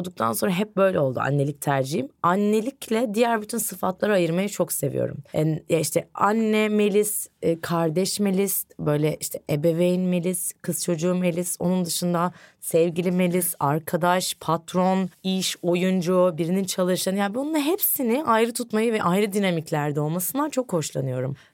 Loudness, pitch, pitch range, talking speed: -23 LUFS, 180 Hz, 170-200 Hz, 135 wpm